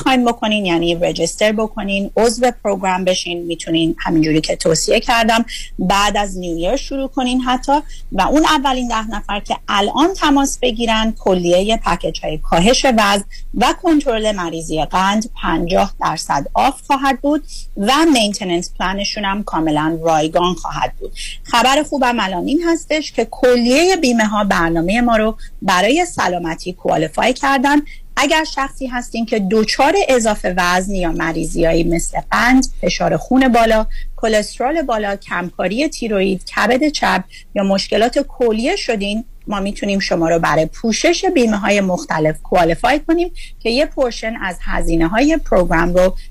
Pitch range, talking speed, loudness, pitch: 180-260 Hz, 140 wpm, -16 LUFS, 215 Hz